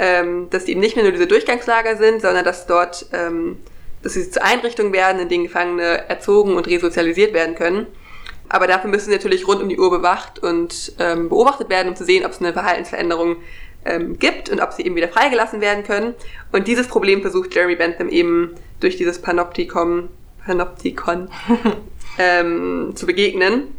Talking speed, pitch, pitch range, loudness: 170 wpm, 185 Hz, 175-235 Hz, -17 LUFS